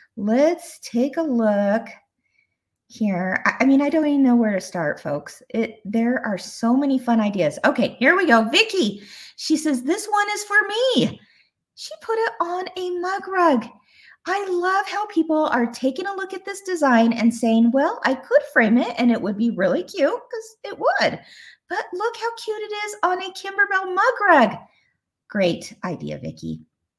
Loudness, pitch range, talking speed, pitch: -21 LUFS, 230-380 Hz, 180 wpm, 280 Hz